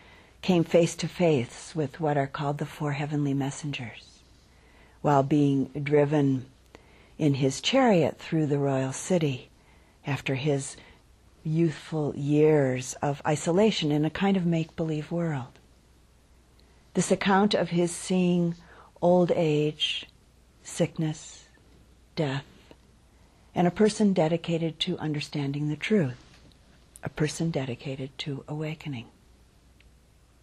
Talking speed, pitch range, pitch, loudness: 110 wpm, 140-170 Hz, 150 Hz, -27 LUFS